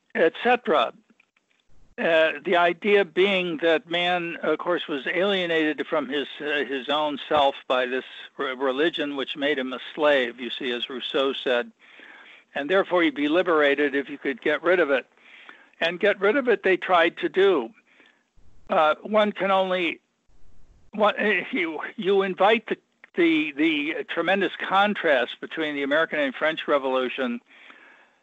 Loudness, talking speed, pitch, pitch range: -23 LUFS, 145 wpm, 170 Hz, 145-195 Hz